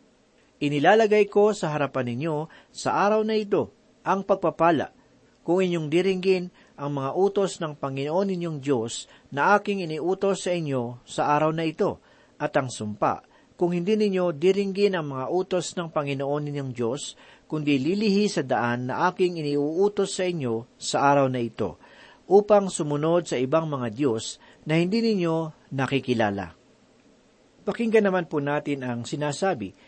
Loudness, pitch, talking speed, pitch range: -25 LUFS, 165 Hz, 145 wpm, 140-190 Hz